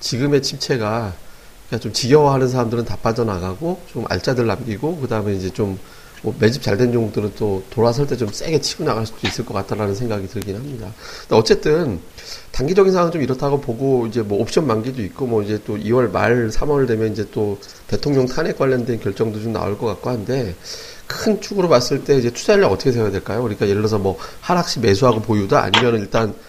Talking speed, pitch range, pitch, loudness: 415 characters per minute, 105-130 Hz, 115 Hz, -19 LUFS